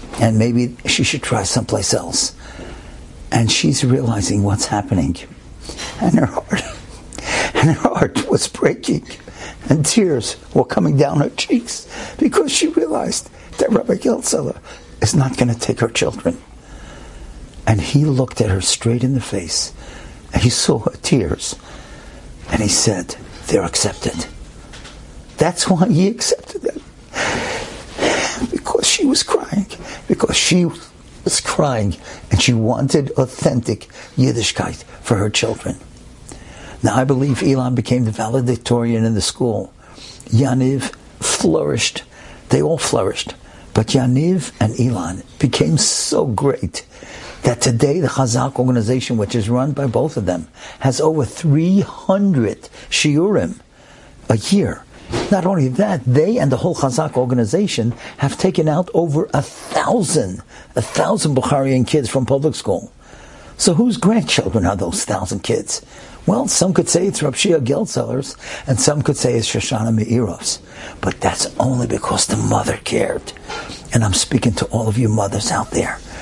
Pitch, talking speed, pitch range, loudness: 130 Hz, 140 wpm, 115-160 Hz, -17 LUFS